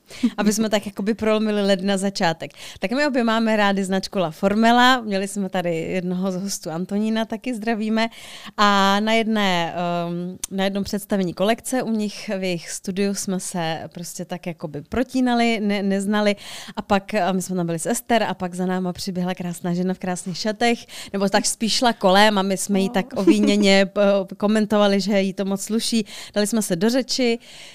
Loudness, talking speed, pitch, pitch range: -21 LUFS, 185 wpm, 200 Hz, 185-220 Hz